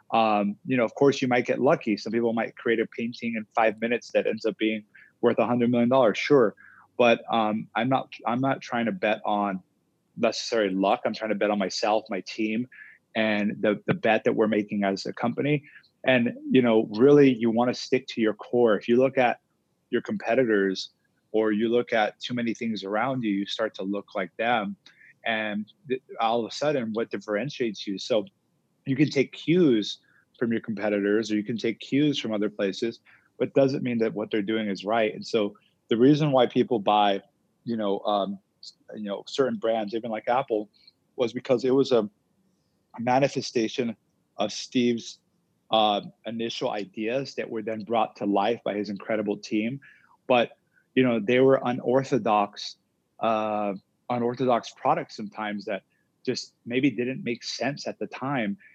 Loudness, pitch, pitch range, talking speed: -26 LUFS, 115 Hz, 105-125 Hz, 185 wpm